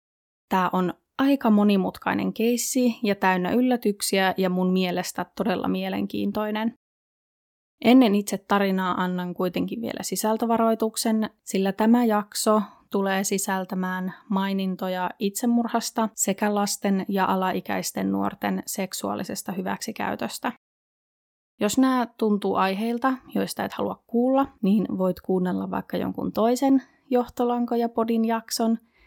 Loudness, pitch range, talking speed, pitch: -24 LUFS, 185-230 Hz, 105 wpm, 205 Hz